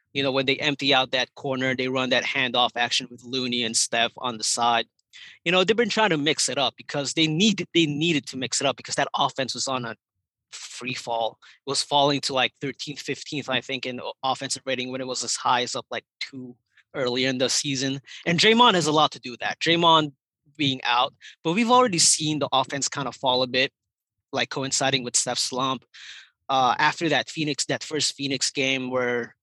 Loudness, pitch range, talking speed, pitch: -23 LUFS, 125-145 Hz, 220 wpm, 135 Hz